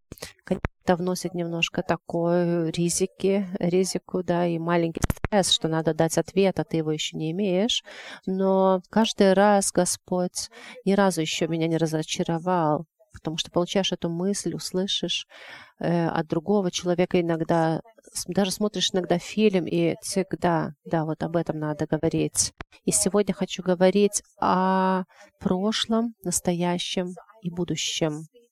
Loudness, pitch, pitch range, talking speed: -25 LUFS, 180 Hz, 165-190 Hz, 130 wpm